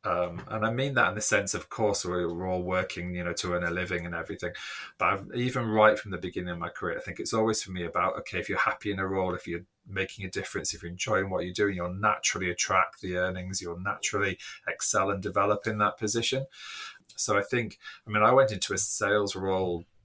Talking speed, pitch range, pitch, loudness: 240 wpm, 90-105 Hz, 95 Hz, -28 LUFS